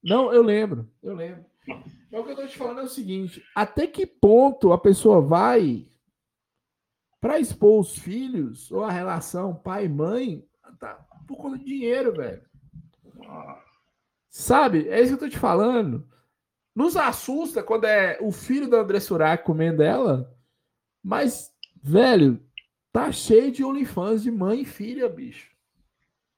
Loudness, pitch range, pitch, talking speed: -22 LUFS, 175-260 Hz, 220 Hz, 150 wpm